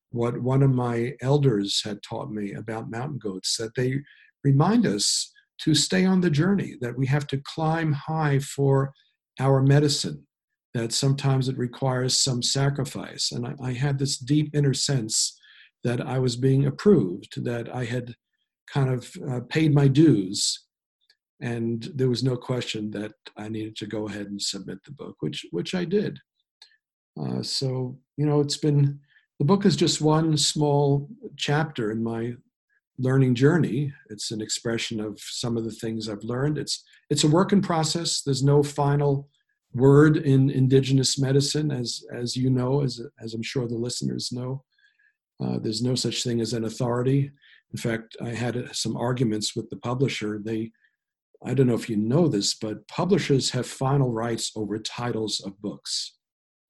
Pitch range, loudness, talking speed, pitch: 115-145 Hz, -25 LUFS, 170 wpm, 130 Hz